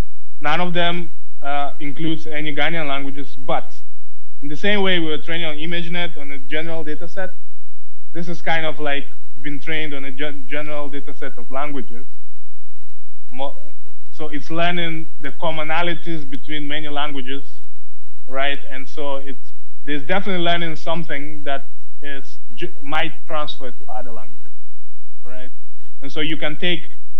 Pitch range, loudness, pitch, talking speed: 140-165 Hz, -25 LUFS, 150 Hz, 150 wpm